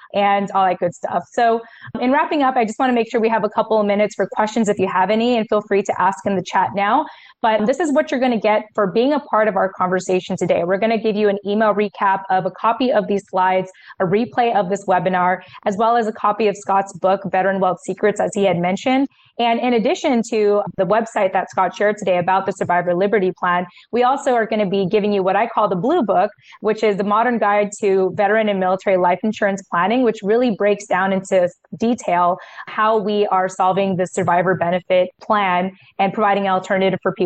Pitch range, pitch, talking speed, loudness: 190-225 Hz, 205 Hz, 235 wpm, -18 LUFS